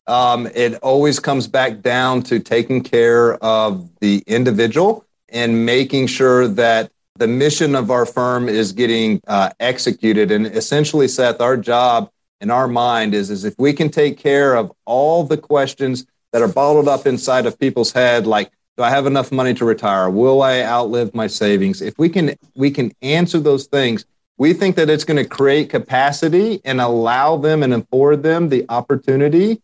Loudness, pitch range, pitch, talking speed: -16 LUFS, 115-145 Hz, 130 Hz, 180 wpm